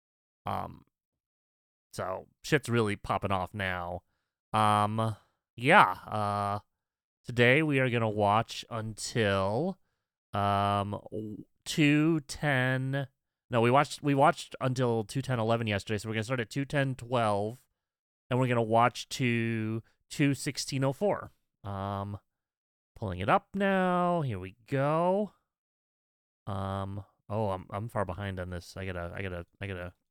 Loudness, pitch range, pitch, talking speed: -30 LUFS, 100-135 Hz, 110 Hz, 135 wpm